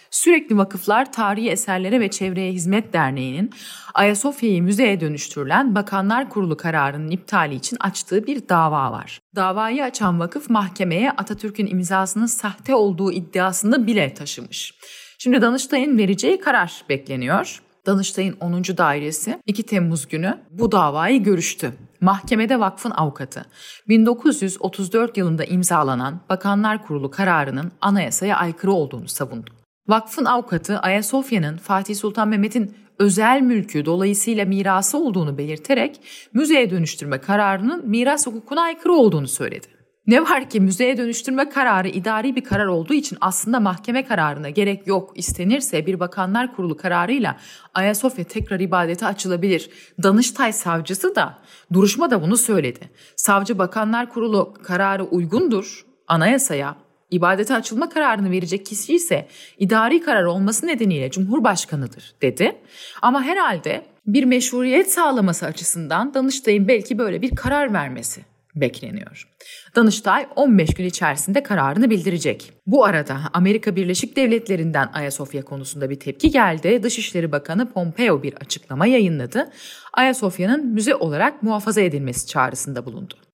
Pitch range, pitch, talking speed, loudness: 175-240 Hz, 200 Hz, 120 wpm, -19 LUFS